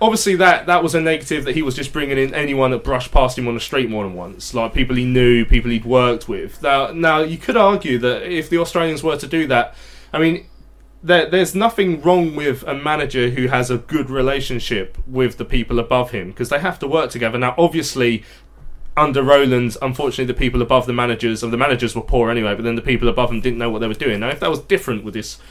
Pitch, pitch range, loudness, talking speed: 130 Hz, 120-155 Hz, -18 LUFS, 245 wpm